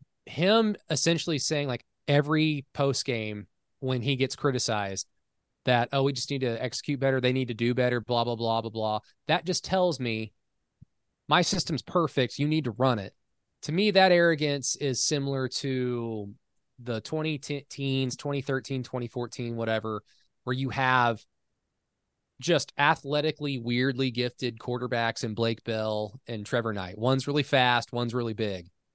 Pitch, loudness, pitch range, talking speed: 130 Hz, -28 LUFS, 115-145 Hz, 150 wpm